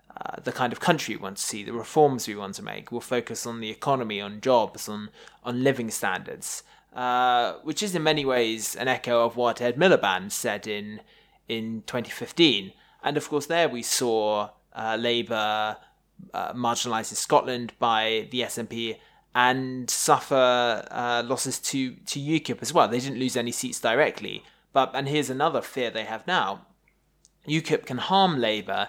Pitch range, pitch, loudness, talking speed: 110-135 Hz, 120 Hz, -25 LUFS, 175 wpm